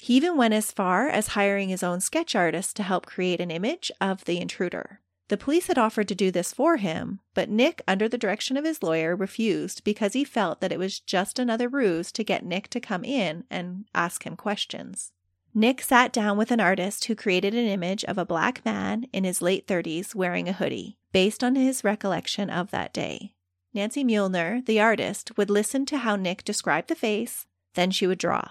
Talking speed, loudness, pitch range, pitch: 210 wpm, -26 LUFS, 180-230 Hz, 205 Hz